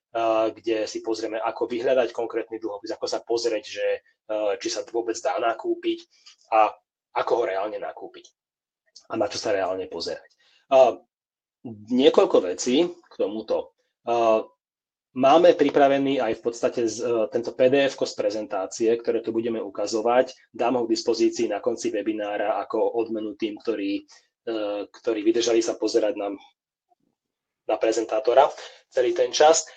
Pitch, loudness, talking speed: 145 Hz, -24 LUFS, 130 wpm